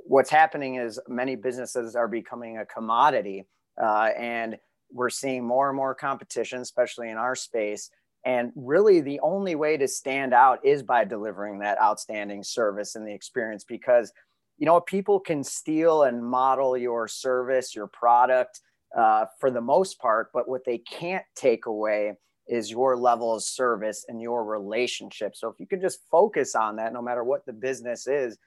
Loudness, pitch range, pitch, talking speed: -25 LUFS, 110-135 Hz, 120 Hz, 175 wpm